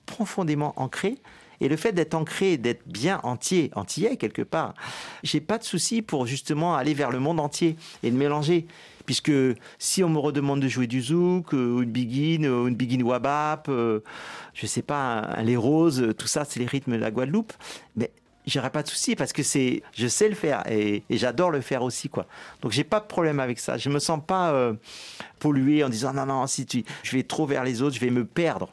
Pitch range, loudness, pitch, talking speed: 125-165 Hz, -25 LUFS, 145 Hz, 215 wpm